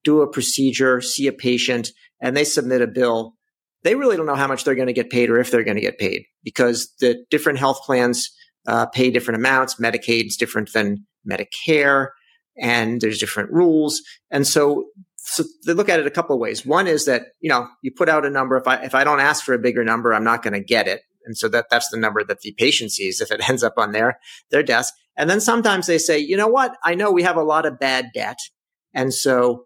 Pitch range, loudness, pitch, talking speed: 120-155 Hz, -19 LUFS, 130 Hz, 245 wpm